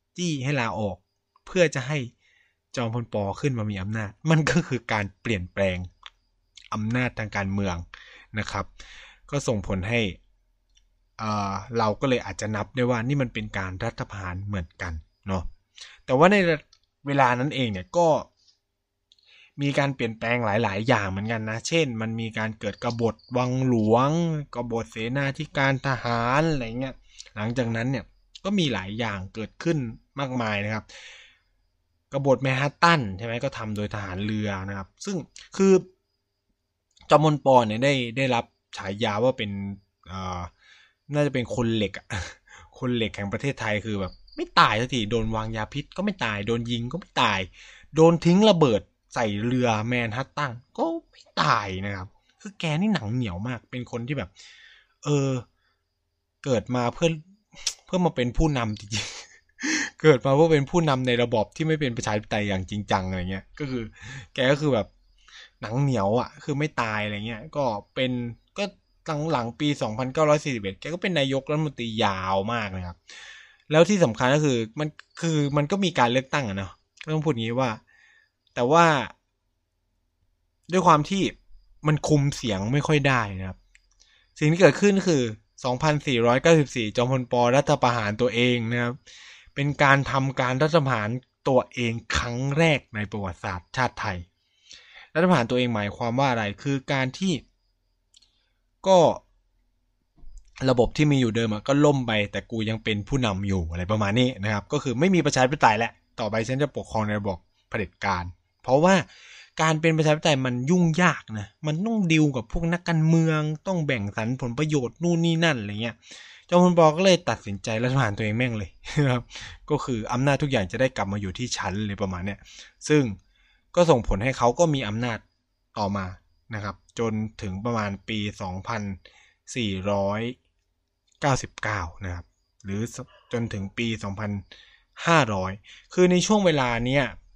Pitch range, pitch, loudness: 100-145 Hz, 120 Hz, -25 LUFS